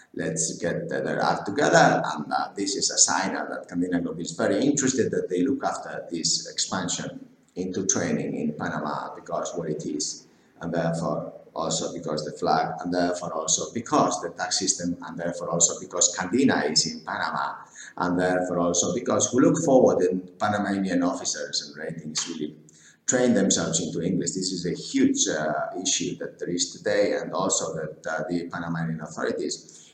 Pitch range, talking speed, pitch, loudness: 80-95 Hz, 175 wpm, 85 Hz, -25 LUFS